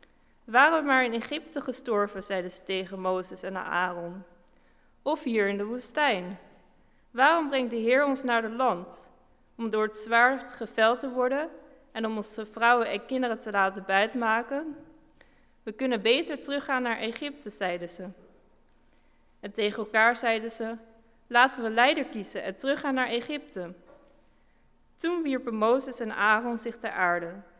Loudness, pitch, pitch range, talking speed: -27 LUFS, 230 Hz, 205-260 Hz, 150 wpm